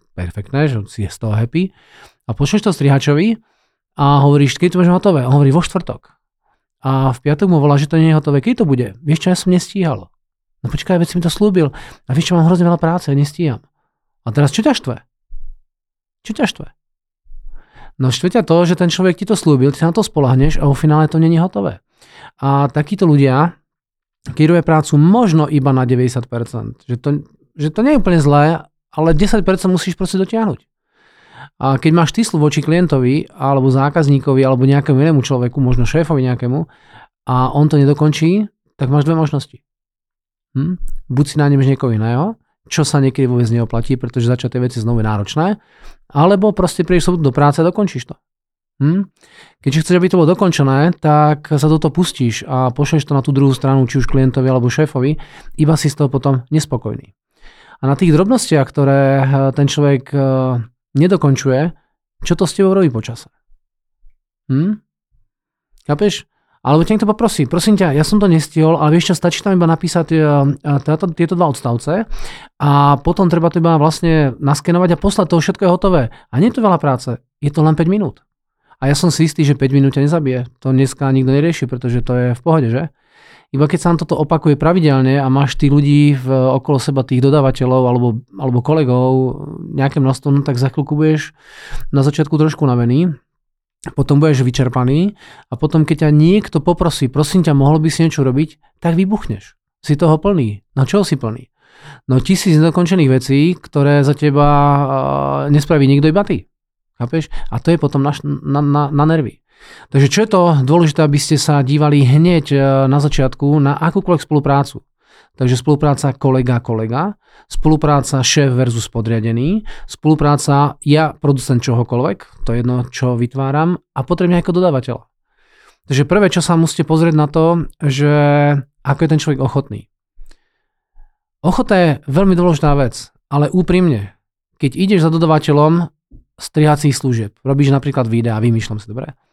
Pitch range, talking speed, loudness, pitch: 135-165 Hz, 175 wpm, -14 LUFS, 145 Hz